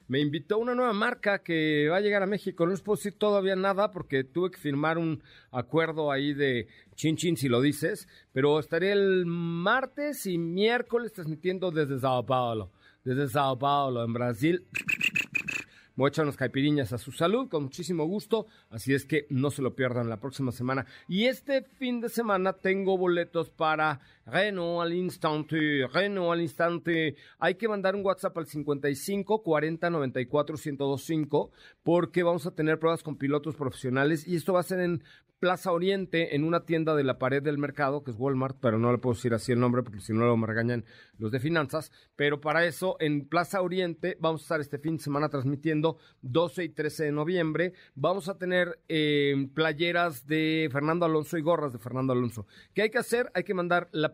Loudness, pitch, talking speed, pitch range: -28 LUFS, 160 Hz, 195 wpm, 140-180 Hz